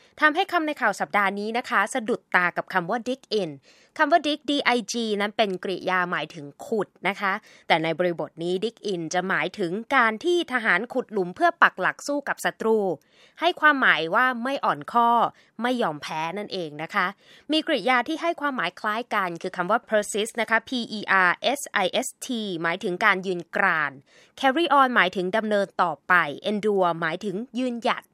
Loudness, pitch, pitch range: -24 LUFS, 210 Hz, 180-250 Hz